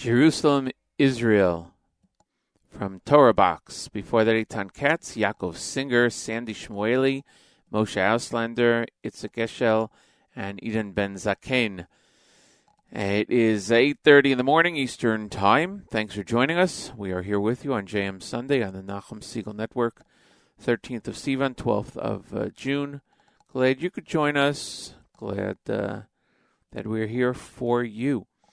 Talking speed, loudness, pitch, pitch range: 135 wpm, -24 LUFS, 115 Hz, 105-135 Hz